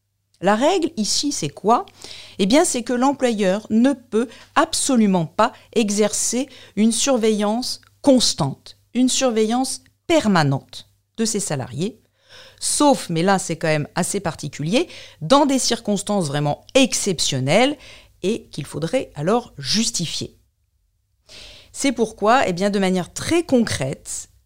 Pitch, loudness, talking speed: 205 Hz, -20 LUFS, 125 wpm